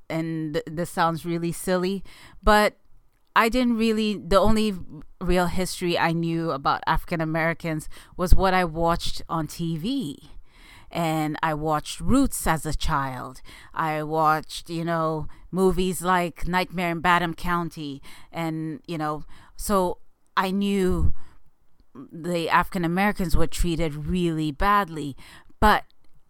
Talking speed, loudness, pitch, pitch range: 125 wpm, -25 LUFS, 170 Hz, 160-185 Hz